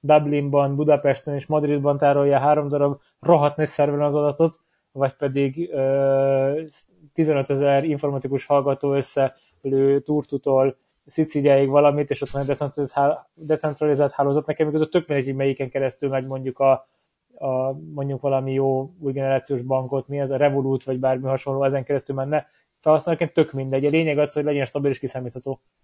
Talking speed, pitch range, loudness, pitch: 155 wpm, 135-150 Hz, -22 LUFS, 140 Hz